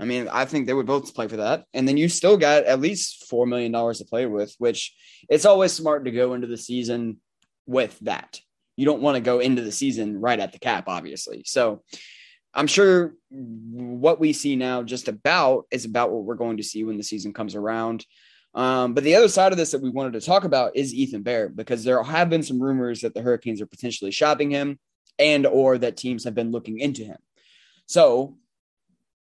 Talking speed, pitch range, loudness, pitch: 220 wpm, 120-150 Hz, -22 LUFS, 125 Hz